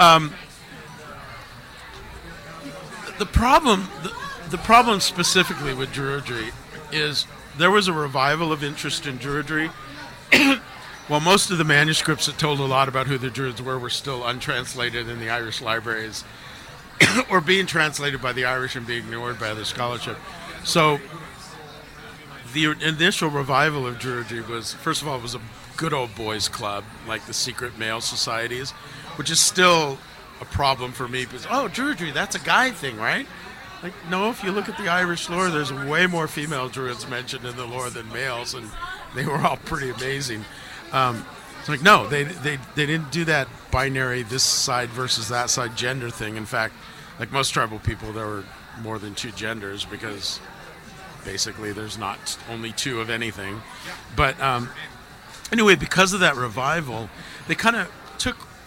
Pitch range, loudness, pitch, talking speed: 120-160 Hz, -22 LUFS, 135 Hz, 170 wpm